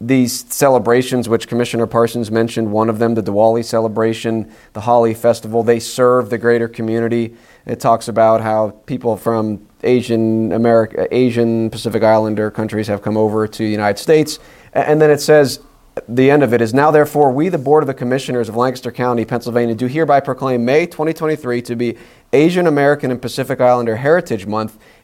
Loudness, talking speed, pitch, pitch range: -15 LUFS, 175 wpm, 120 Hz, 115-130 Hz